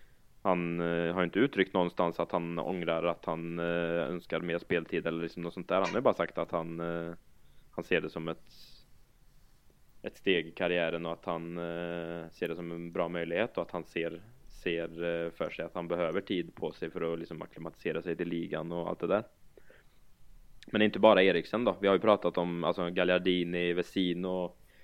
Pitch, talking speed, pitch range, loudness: 85 Hz, 190 wpm, 85-90 Hz, -32 LUFS